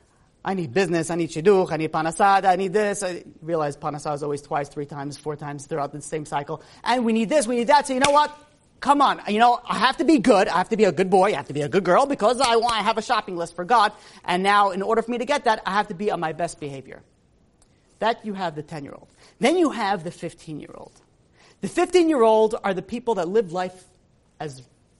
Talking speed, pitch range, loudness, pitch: 270 wpm, 160-230 Hz, -22 LUFS, 195 Hz